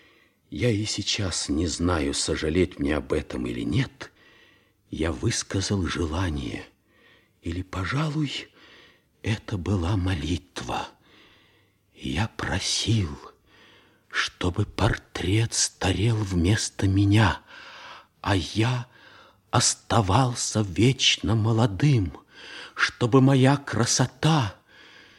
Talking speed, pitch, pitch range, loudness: 80 wpm, 105 Hz, 90-120 Hz, -25 LUFS